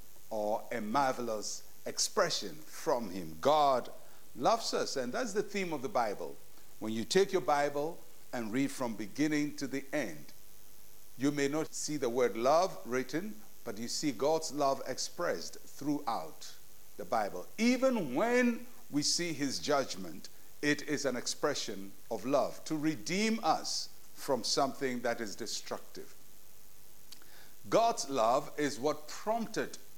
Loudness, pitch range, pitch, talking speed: -34 LUFS, 125-165 Hz, 145 Hz, 140 wpm